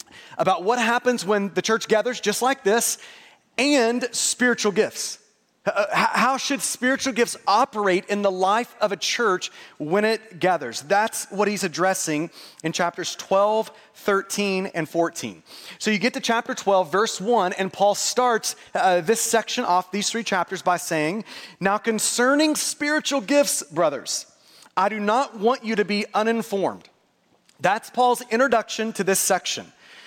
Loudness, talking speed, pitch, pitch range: -22 LUFS, 150 wpm, 215 Hz, 195-245 Hz